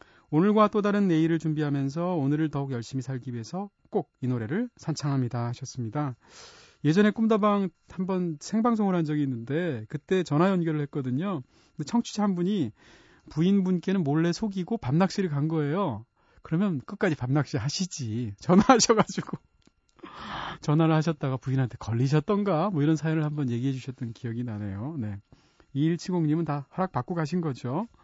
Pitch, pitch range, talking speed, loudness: 155 Hz, 135-190 Hz, 350 characters per minute, -27 LUFS